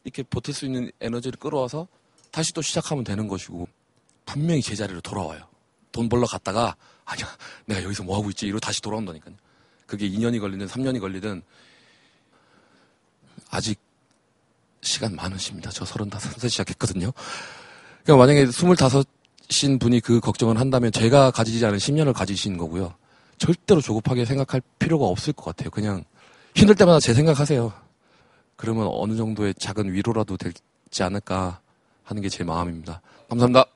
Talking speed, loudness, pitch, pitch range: 345 characters per minute, -23 LUFS, 115 Hz, 100-130 Hz